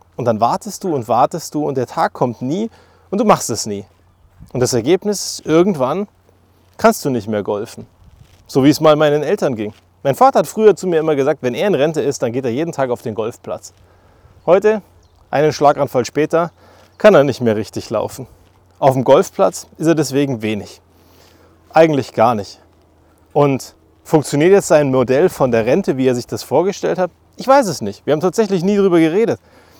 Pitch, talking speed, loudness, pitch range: 130 Hz, 200 wpm, -16 LUFS, 100-165 Hz